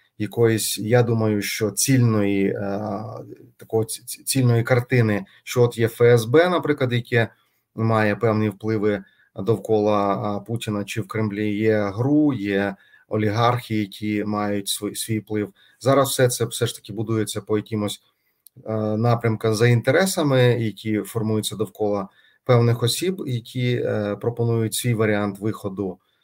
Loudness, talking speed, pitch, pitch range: -22 LUFS, 120 wpm, 110 Hz, 105-120 Hz